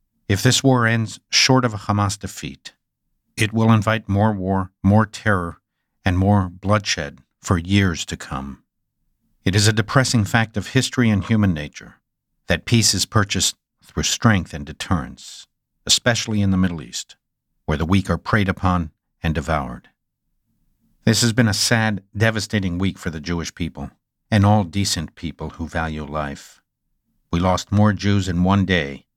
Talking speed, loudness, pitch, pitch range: 165 wpm, -19 LUFS, 100 Hz, 85-110 Hz